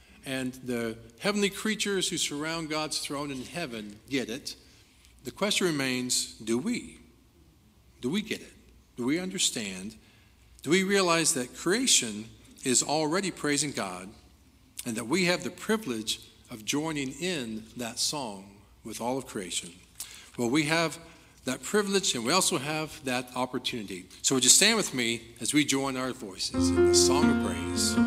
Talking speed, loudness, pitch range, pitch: 160 wpm, -28 LUFS, 115-165 Hz, 130 Hz